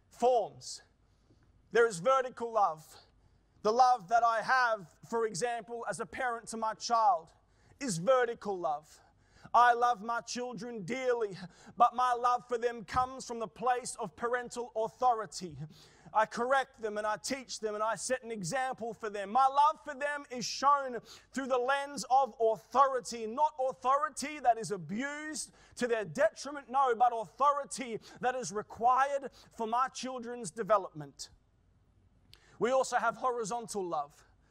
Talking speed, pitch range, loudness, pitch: 150 wpm, 210-255 Hz, -32 LUFS, 235 Hz